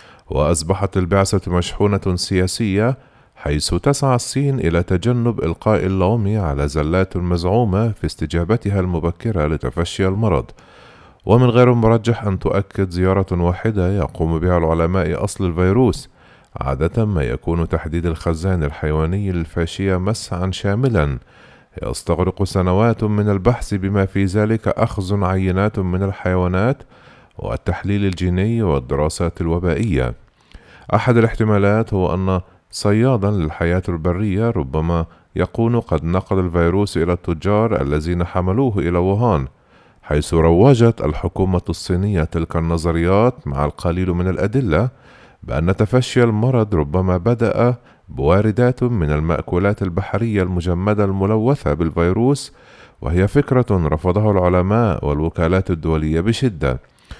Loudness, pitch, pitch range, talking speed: -18 LUFS, 95 Hz, 85-110 Hz, 105 wpm